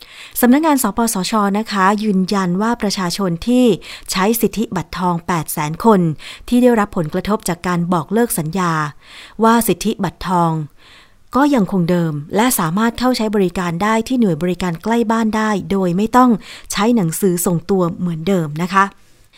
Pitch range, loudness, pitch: 175-225 Hz, -16 LUFS, 195 Hz